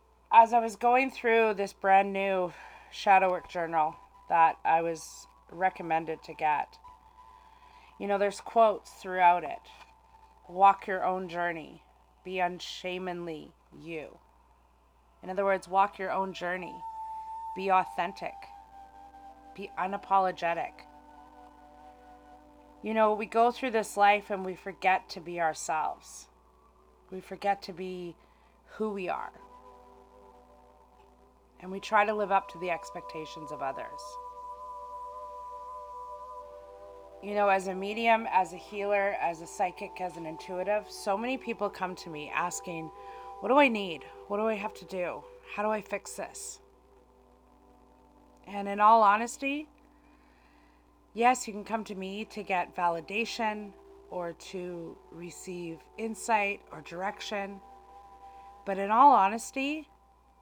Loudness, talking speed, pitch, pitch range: -29 LUFS, 130 wpm, 195 Hz, 170-220 Hz